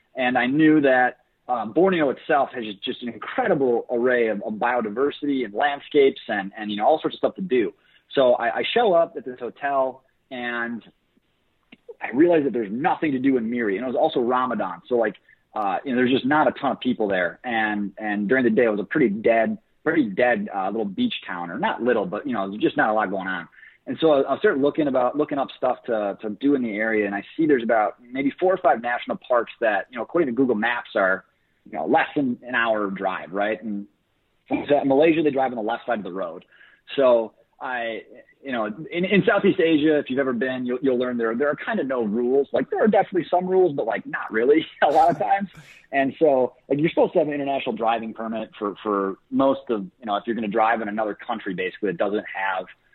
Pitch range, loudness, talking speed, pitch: 110-150 Hz, -22 LUFS, 240 wpm, 125 Hz